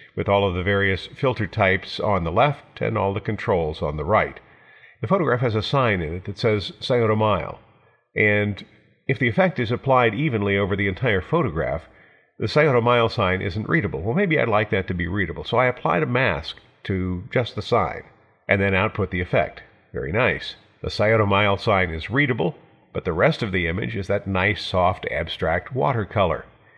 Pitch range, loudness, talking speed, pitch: 100-120 Hz, -22 LUFS, 195 wpm, 105 Hz